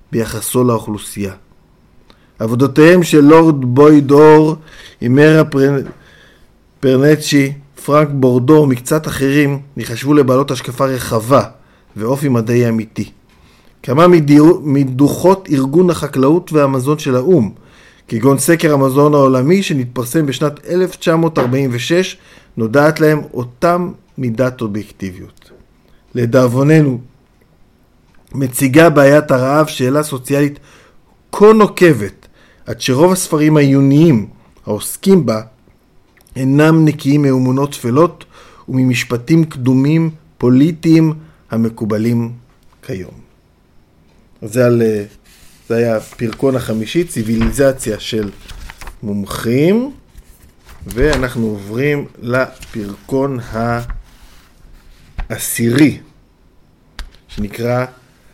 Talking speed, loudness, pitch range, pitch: 75 wpm, -13 LUFS, 115-150 Hz, 135 Hz